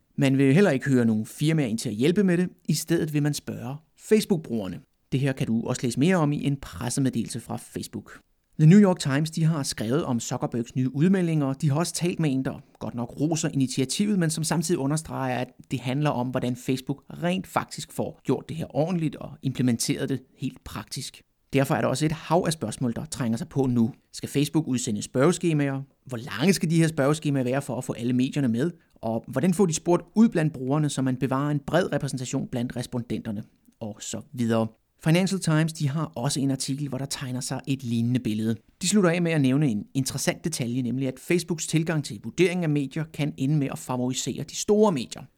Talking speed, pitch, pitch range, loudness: 215 wpm, 140 Hz, 125-160 Hz, -26 LUFS